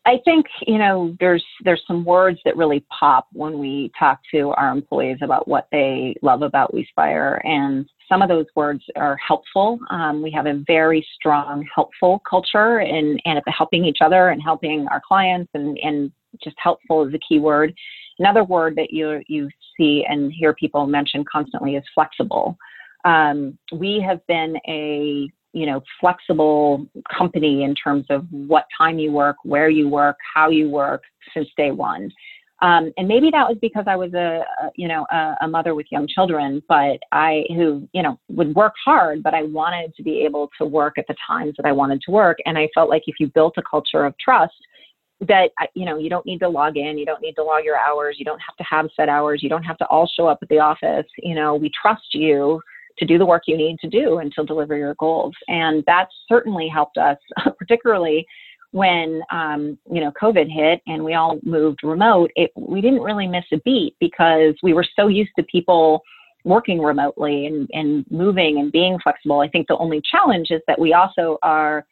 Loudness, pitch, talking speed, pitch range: -18 LUFS, 160 Hz, 205 wpm, 150-180 Hz